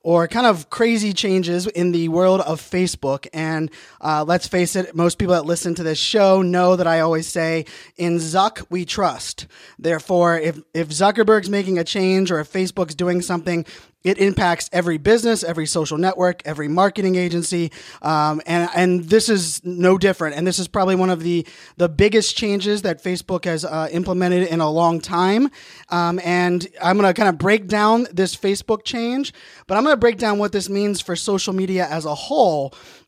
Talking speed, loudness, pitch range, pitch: 190 wpm, -19 LUFS, 170-195 Hz, 180 Hz